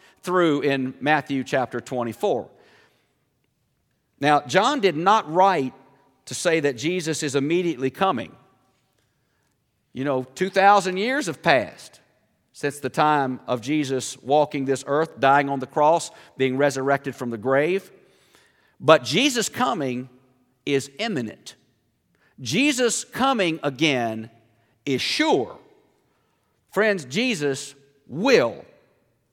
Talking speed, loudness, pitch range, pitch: 110 wpm, -22 LUFS, 130-185 Hz, 145 Hz